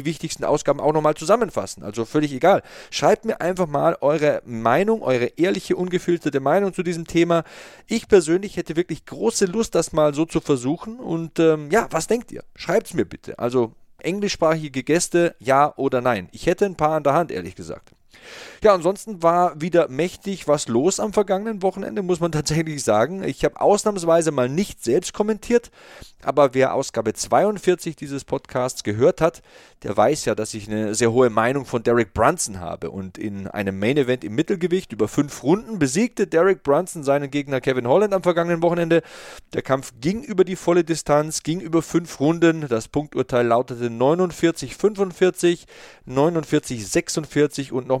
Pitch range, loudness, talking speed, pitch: 135-180 Hz, -21 LUFS, 170 wpm, 160 Hz